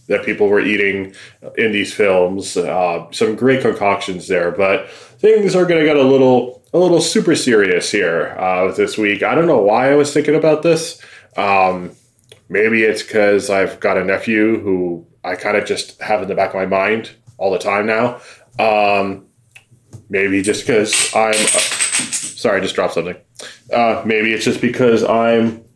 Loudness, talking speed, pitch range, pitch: -15 LUFS, 180 wpm, 100-140 Hz, 110 Hz